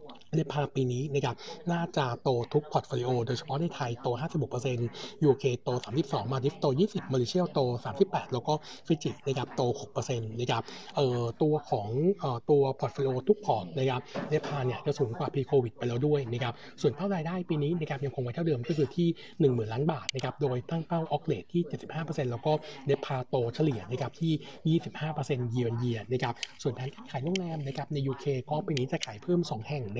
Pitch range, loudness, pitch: 125-155 Hz, -31 LUFS, 140 Hz